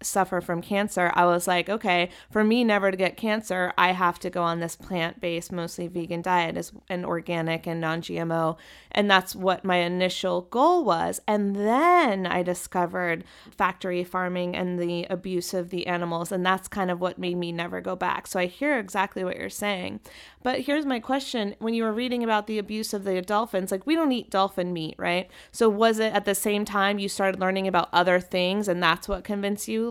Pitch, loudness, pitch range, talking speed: 185 Hz, -25 LUFS, 175-210 Hz, 205 wpm